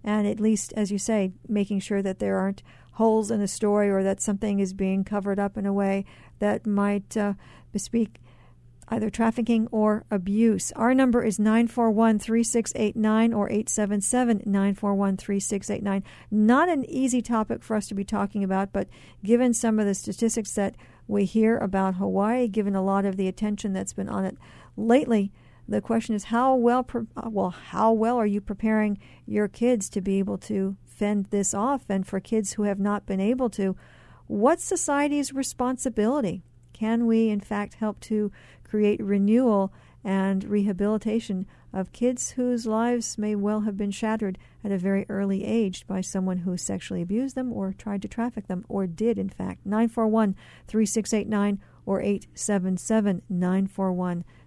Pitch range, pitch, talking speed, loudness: 195-225 Hz, 210 Hz, 160 wpm, -25 LUFS